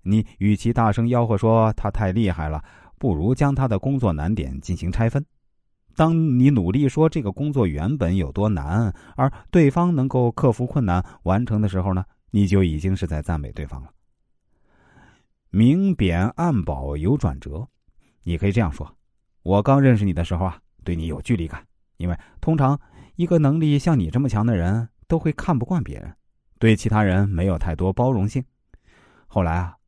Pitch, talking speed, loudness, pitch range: 105 Hz, 260 characters per minute, -21 LUFS, 90-130 Hz